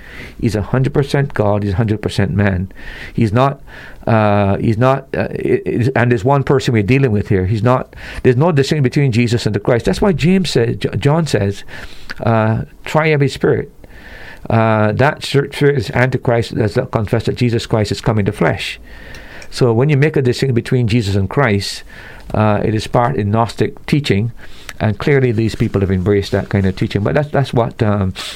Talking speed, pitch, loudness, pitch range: 195 wpm, 120 Hz, -15 LUFS, 105-135 Hz